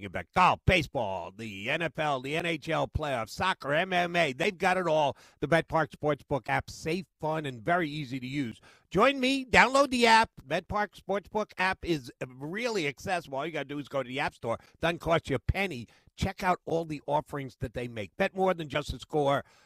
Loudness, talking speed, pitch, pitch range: -29 LUFS, 205 wpm, 155 Hz, 135-180 Hz